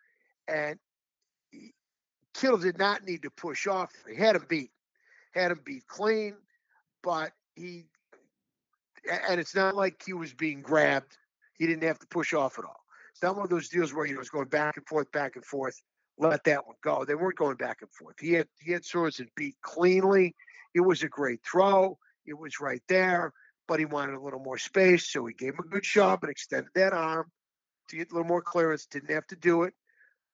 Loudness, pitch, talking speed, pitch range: -29 LUFS, 175 Hz, 210 wpm, 155-190 Hz